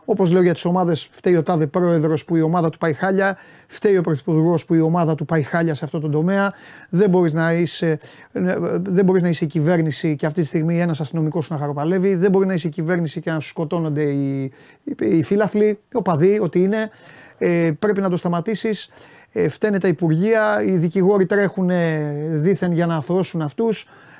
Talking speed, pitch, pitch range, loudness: 190 wpm, 175 Hz, 160-190 Hz, -19 LUFS